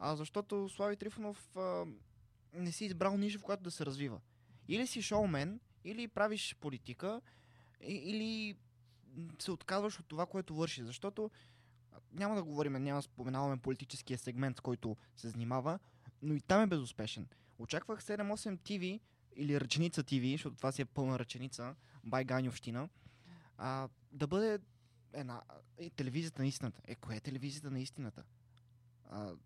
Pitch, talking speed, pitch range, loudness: 140 Hz, 150 wpm, 120-185 Hz, -40 LUFS